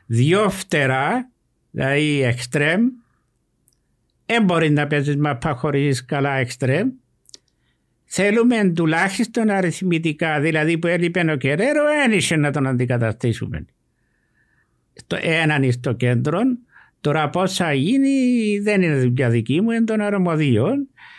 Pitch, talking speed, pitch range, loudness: 165 Hz, 110 wpm, 140-210 Hz, -19 LUFS